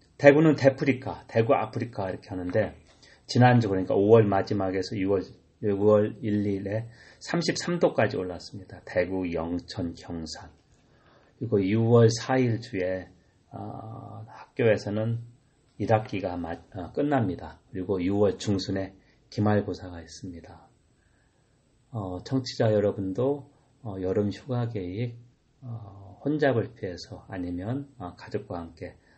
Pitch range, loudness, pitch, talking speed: 95-125 Hz, -26 LUFS, 105 Hz, 230 characters per minute